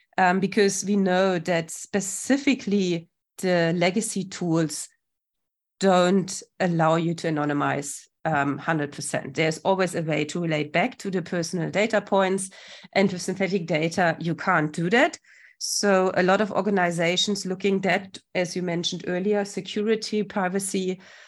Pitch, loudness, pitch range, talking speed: 185 Hz, -24 LUFS, 170-195 Hz, 140 wpm